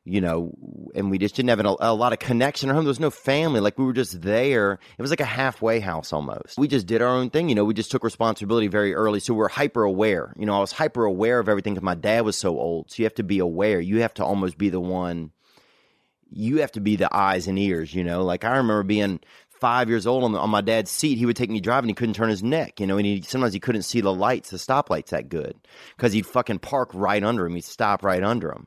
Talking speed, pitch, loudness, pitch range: 280 wpm, 110 Hz, -23 LUFS, 100-120 Hz